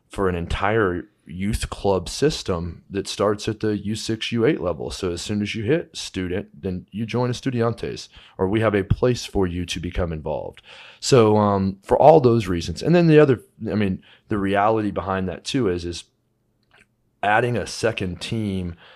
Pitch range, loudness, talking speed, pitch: 90-115 Hz, -22 LUFS, 190 wpm, 100 Hz